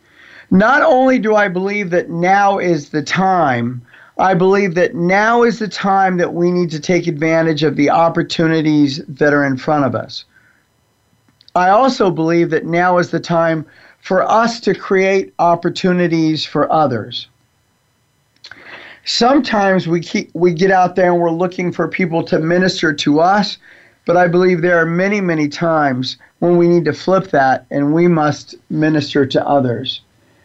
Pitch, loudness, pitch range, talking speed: 170 Hz, -14 LUFS, 150-185 Hz, 165 wpm